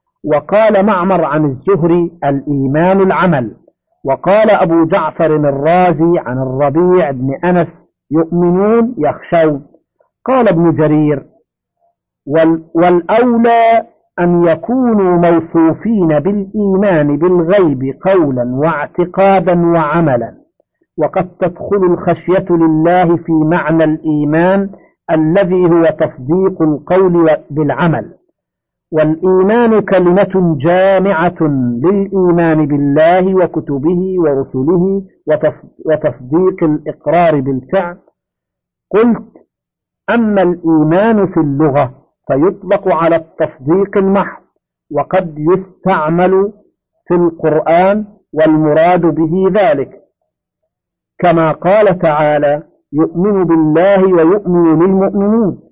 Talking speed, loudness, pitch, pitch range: 80 wpm, -12 LUFS, 175 Hz, 155-190 Hz